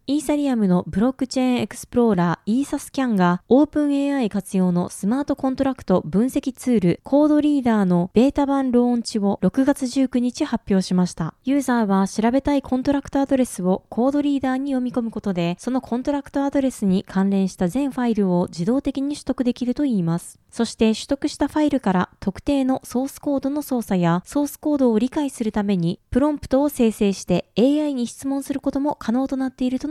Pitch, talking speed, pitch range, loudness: 250 Hz, 445 characters per minute, 200-280 Hz, -21 LUFS